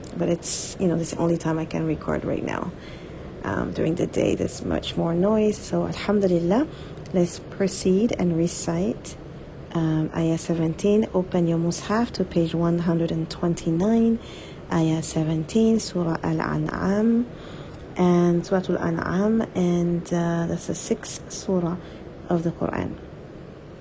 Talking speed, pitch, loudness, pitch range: 135 wpm, 175 Hz, -24 LUFS, 165-195 Hz